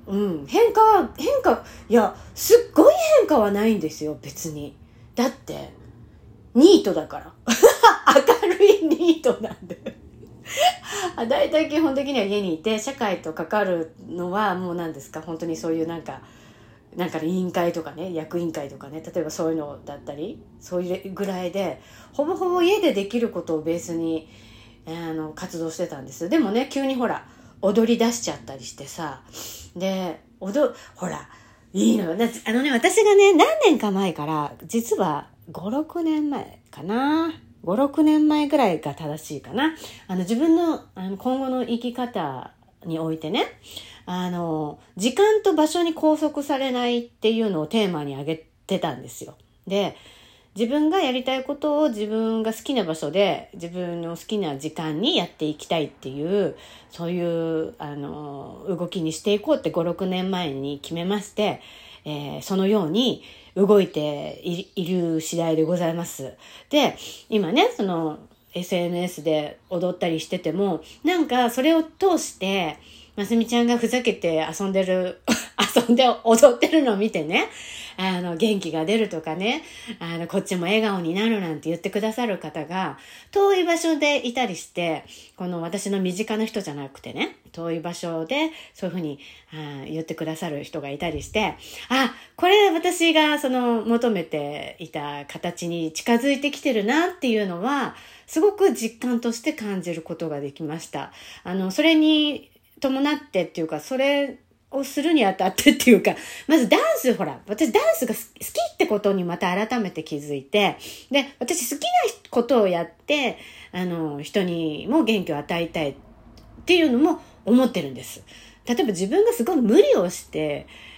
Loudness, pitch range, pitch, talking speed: -22 LUFS, 165-265 Hz, 195 Hz, 305 characters per minute